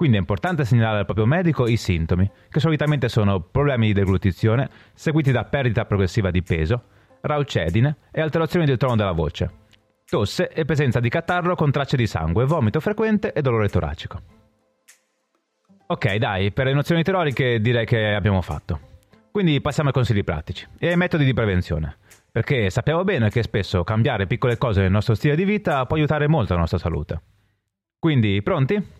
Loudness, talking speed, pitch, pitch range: -21 LUFS, 170 wpm, 115 Hz, 100-150 Hz